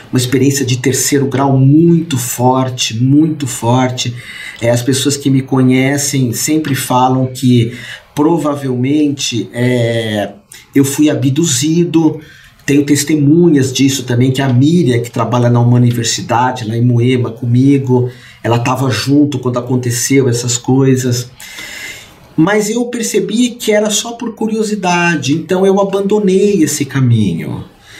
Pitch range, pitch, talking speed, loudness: 125-155 Hz, 135 Hz, 125 wpm, -12 LUFS